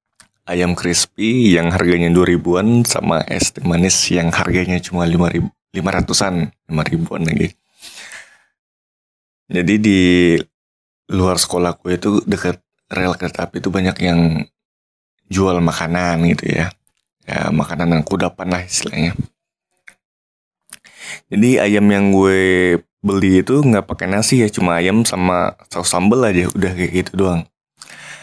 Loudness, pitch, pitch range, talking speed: -16 LUFS, 90 Hz, 85-95 Hz, 130 wpm